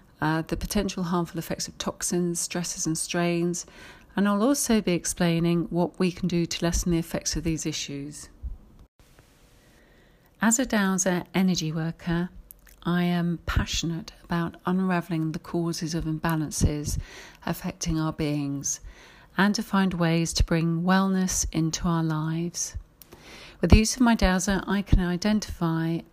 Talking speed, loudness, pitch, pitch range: 140 wpm, -26 LUFS, 170 Hz, 165-185 Hz